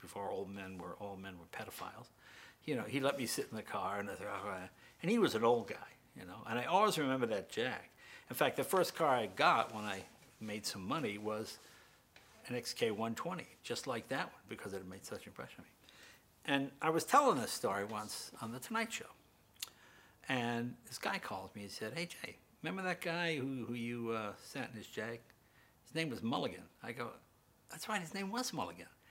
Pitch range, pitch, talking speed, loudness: 105-160 Hz, 120 Hz, 220 wpm, -39 LUFS